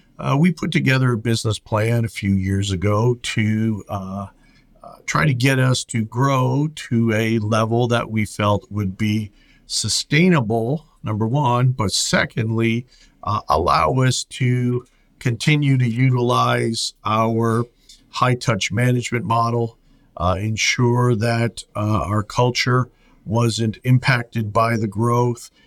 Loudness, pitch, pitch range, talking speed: -19 LUFS, 115 Hz, 110-125 Hz, 130 wpm